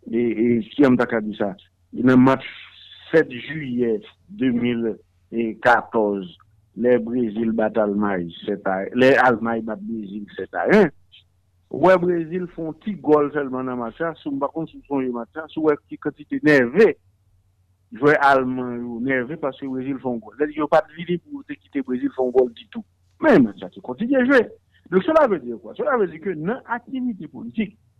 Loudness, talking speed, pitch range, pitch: -21 LUFS, 190 wpm, 110-155 Hz, 125 Hz